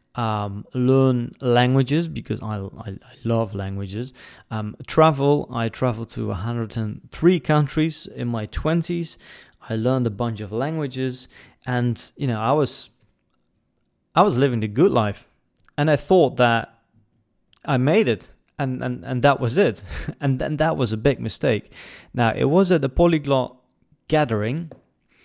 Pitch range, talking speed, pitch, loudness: 115-145 Hz, 150 wpm, 125 Hz, -22 LUFS